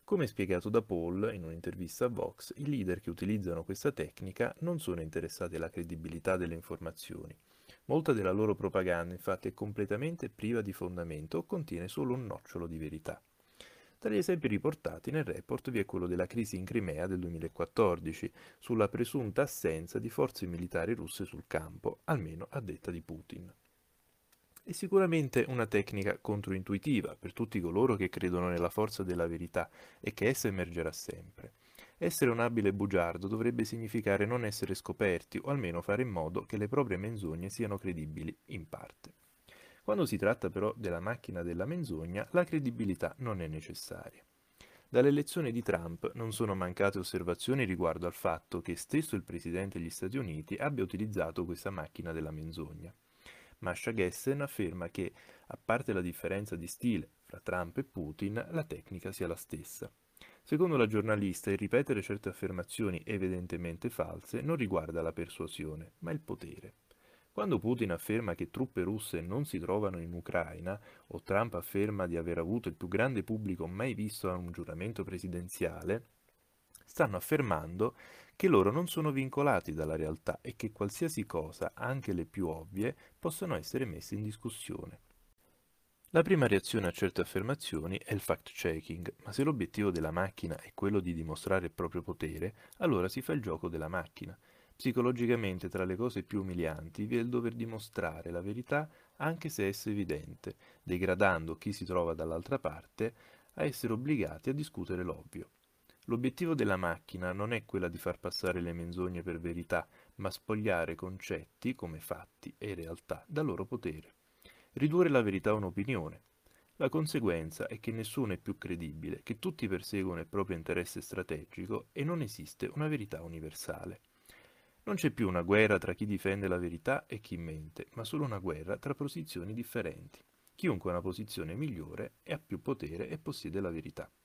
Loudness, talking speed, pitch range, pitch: -36 LUFS, 165 wpm, 85-115 Hz, 100 Hz